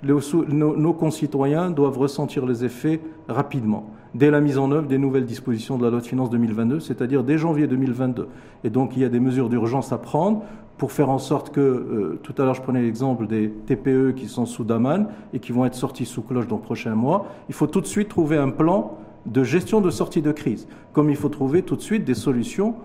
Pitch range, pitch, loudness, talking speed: 125-150 Hz, 135 Hz, -22 LUFS, 225 wpm